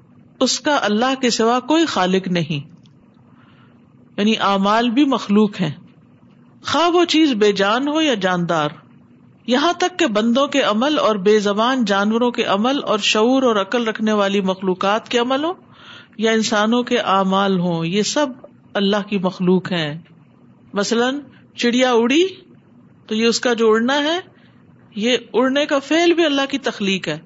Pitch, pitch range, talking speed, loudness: 225 Hz, 200-270 Hz, 160 wpm, -17 LUFS